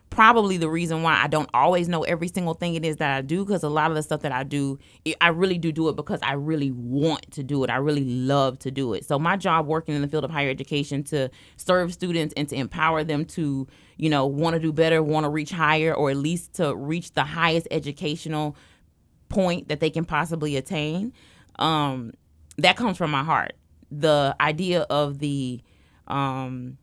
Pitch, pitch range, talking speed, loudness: 150 Hz, 140-165 Hz, 215 wpm, -24 LUFS